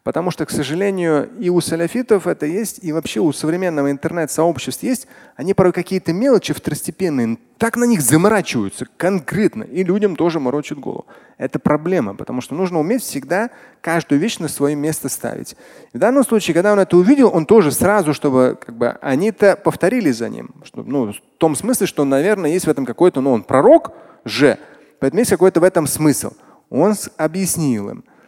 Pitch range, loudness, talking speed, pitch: 150-210 Hz, -17 LUFS, 180 wpm, 175 Hz